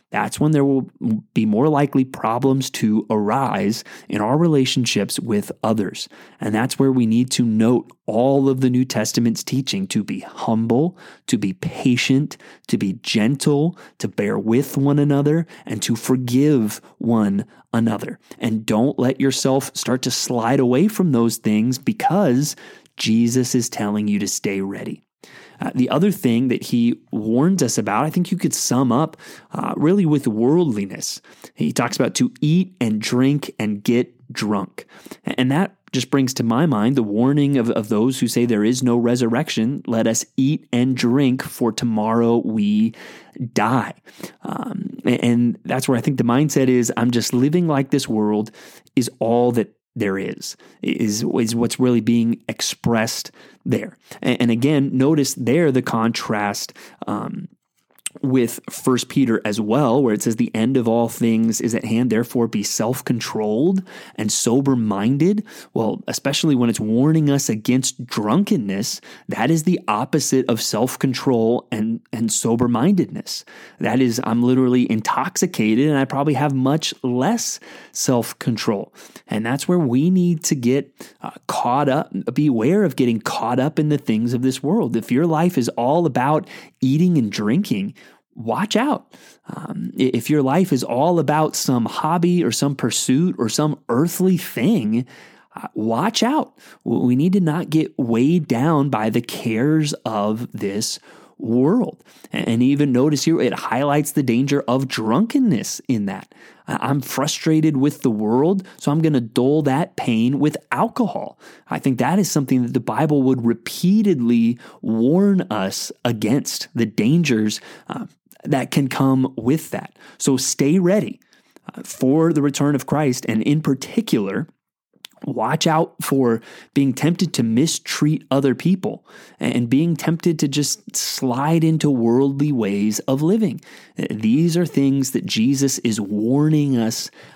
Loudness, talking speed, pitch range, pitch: -19 LUFS, 155 wpm, 115-150 Hz, 130 Hz